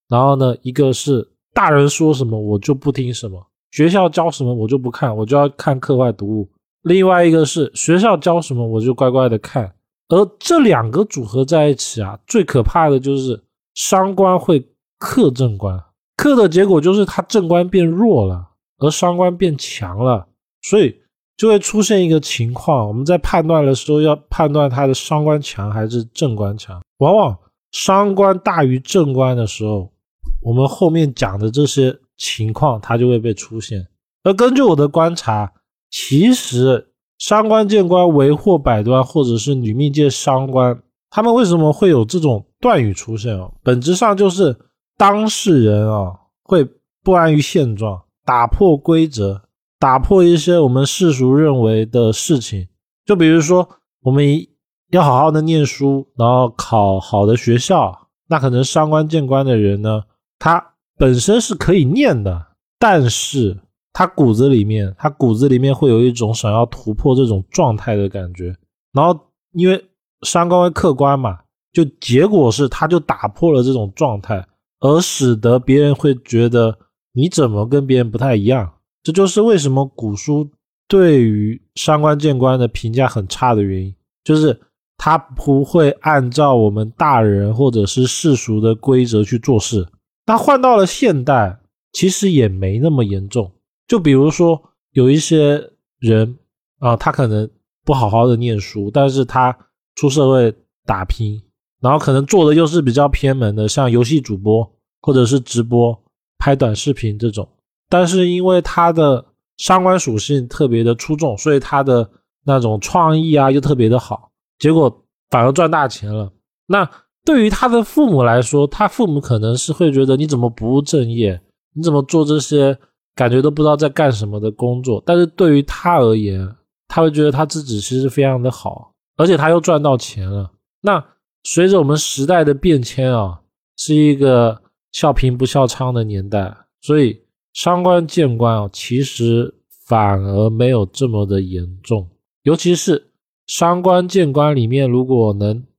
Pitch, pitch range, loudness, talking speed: 135 Hz, 115-160 Hz, -14 LUFS, 245 characters per minute